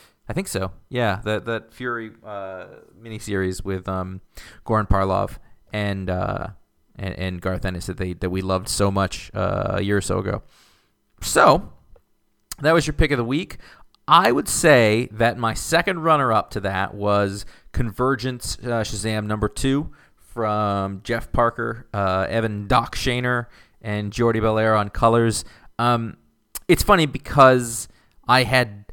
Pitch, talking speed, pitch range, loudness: 105 Hz, 155 wpm, 95-120 Hz, -21 LUFS